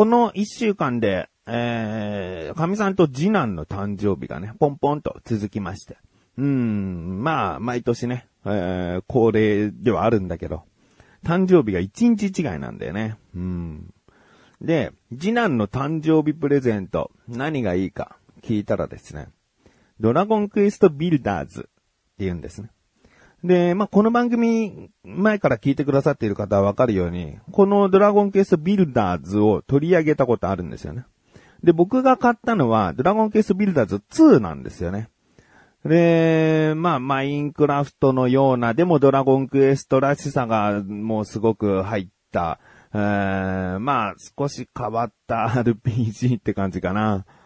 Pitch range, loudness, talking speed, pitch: 105-170 Hz, -21 LUFS, 305 characters per minute, 125 Hz